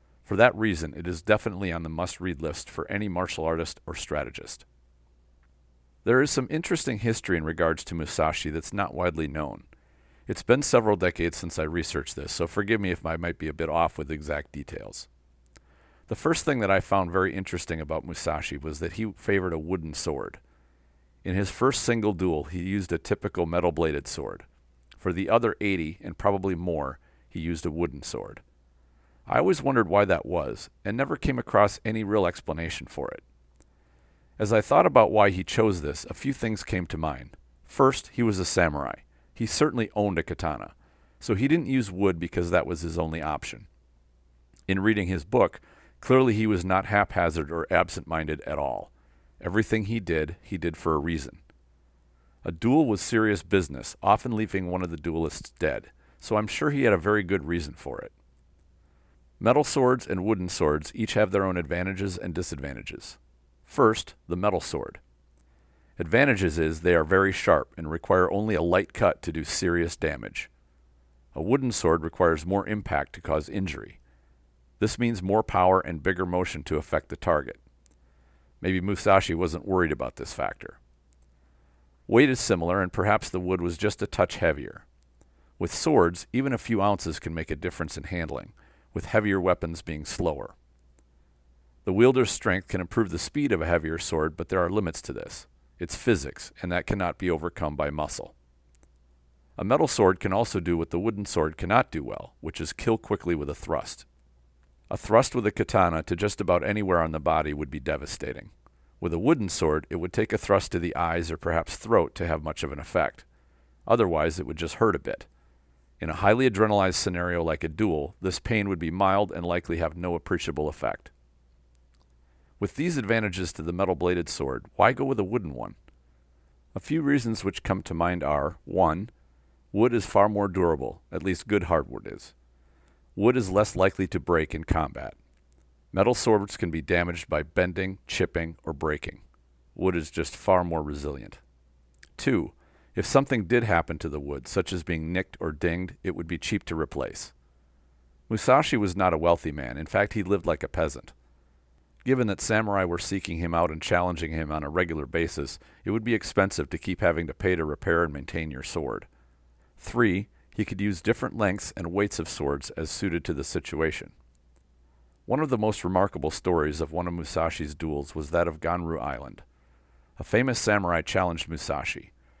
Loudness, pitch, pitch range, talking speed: -26 LUFS, 85 Hz, 65-95 Hz, 185 wpm